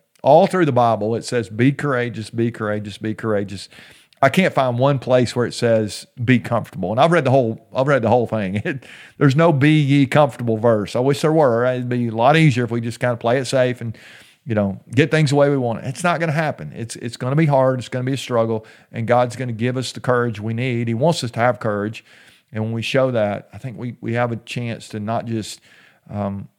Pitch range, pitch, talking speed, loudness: 115-135 Hz, 120 Hz, 260 wpm, -19 LUFS